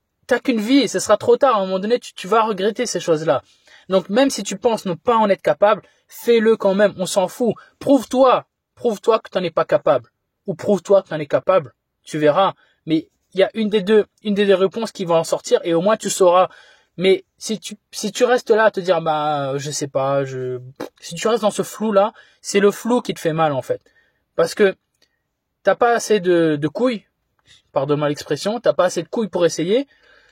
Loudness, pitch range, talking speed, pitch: -19 LUFS, 170-225 Hz, 235 wpm, 200 Hz